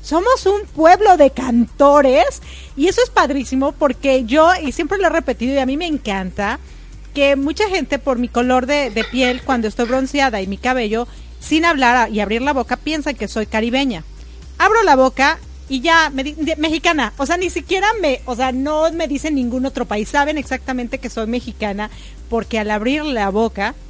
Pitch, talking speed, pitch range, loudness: 270 Hz, 195 wpm, 245-315 Hz, -16 LUFS